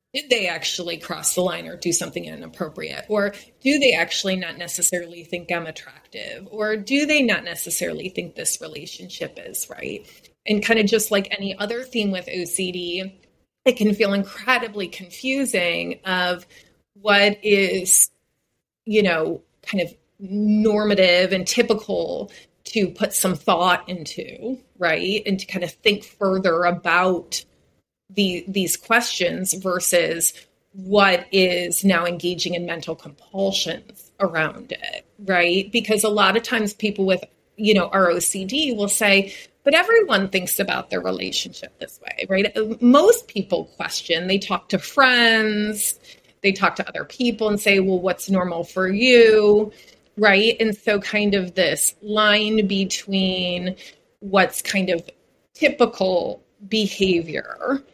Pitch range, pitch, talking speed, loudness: 180-215 Hz, 195 Hz, 140 wpm, -20 LUFS